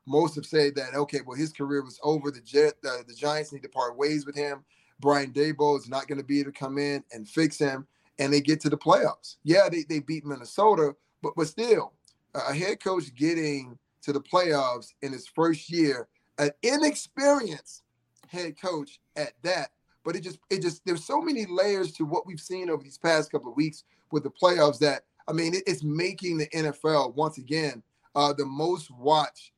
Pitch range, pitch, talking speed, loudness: 140-170 Hz, 150 Hz, 205 wpm, -27 LUFS